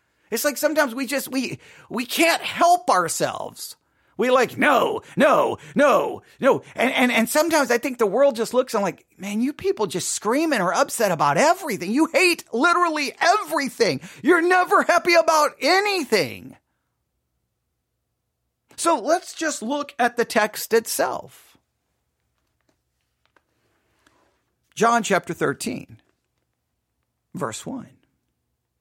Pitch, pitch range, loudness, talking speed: 280 Hz, 225-330 Hz, -20 LUFS, 125 wpm